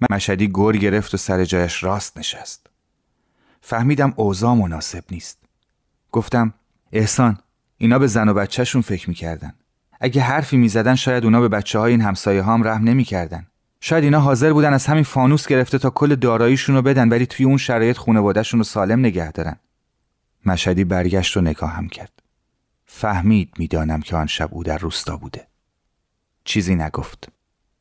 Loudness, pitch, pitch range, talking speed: -18 LUFS, 110 Hz, 95-125 Hz, 160 wpm